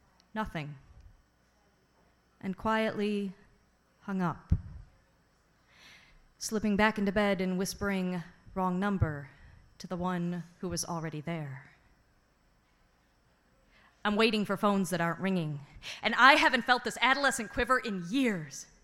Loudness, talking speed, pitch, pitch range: -30 LUFS, 115 wpm, 185 Hz, 150-210 Hz